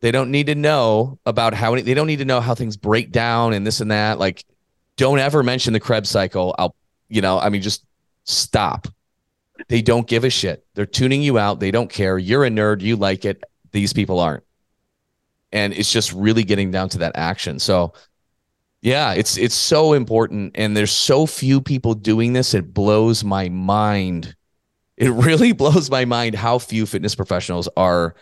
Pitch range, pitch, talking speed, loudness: 100-120 Hz, 110 Hz, 195 wpm, -18 LUFS